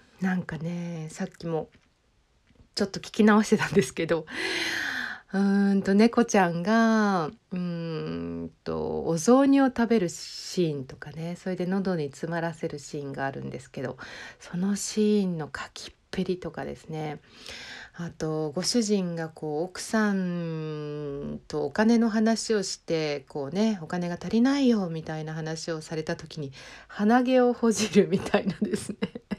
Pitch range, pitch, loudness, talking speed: 155-210 Hz, 175 Hz, -27 LUFS, 285 characters per minute